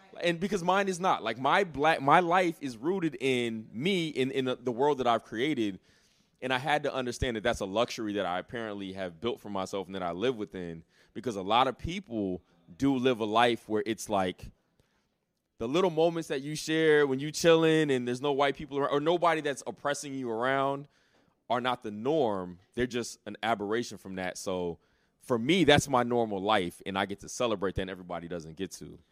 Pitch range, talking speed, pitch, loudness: 100-145 Hz, 215 wpm, 120 Hz, -30 LUFS